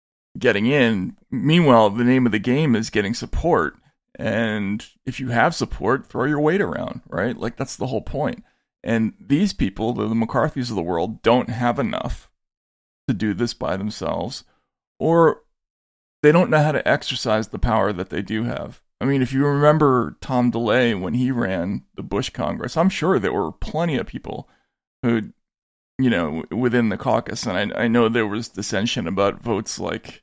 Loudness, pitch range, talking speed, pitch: -21 LUFS, 105-130 Hz, 185 wpm, 115 Hz